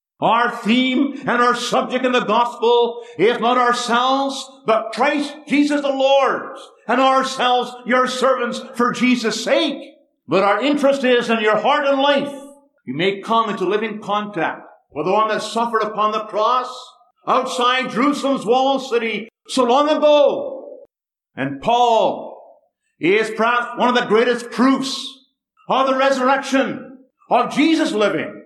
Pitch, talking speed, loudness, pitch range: 250 Hz, 145 wpm, -18 LUFS, 230-275 Hz